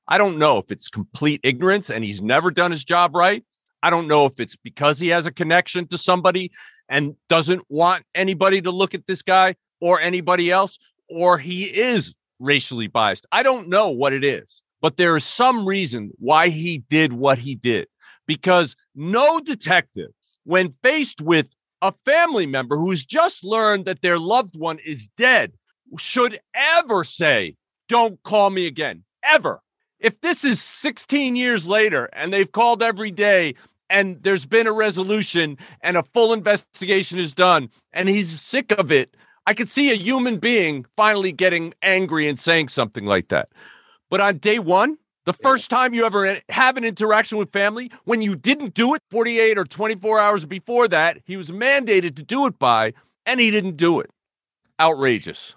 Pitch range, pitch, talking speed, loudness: 165-225 Hz, 190 Hz, 180 wpm, -19 LUFS